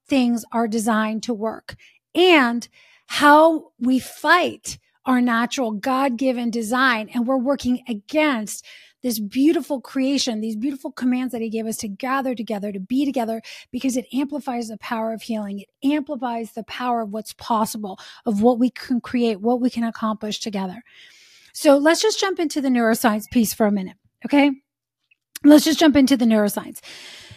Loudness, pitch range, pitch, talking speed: -20 LUFS, 225-280 Hz, 245 Hz, 165 wpm